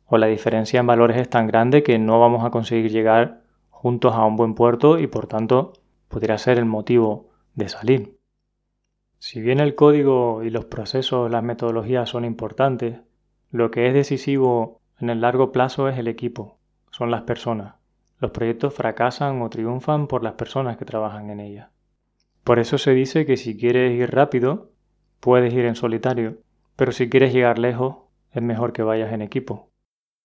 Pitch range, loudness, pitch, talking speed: 115-130 Hz, -20 LUFS, 120 Hz, 175 wpm